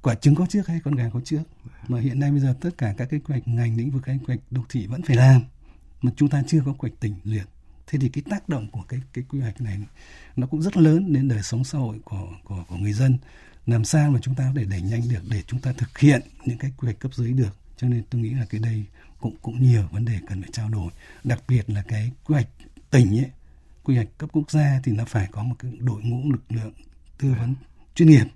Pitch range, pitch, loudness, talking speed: 110-135 Hz, 125 Hz, -23 LUFS, 275 wpm